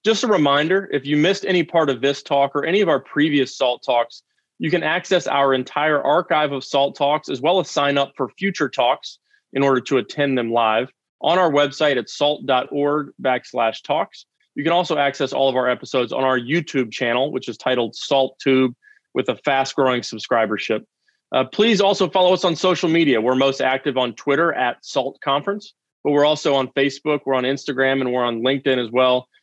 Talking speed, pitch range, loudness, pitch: 205 wpm, 130-150 Hz, -19 LUFS, 140 Hz